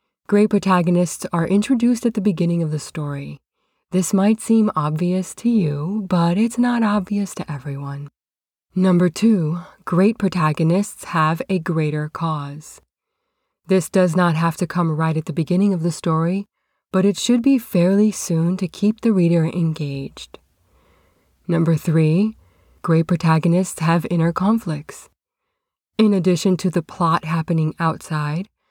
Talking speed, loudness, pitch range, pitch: 140 wpm, -19 LUFS, 160-200 Hz, 175 Hz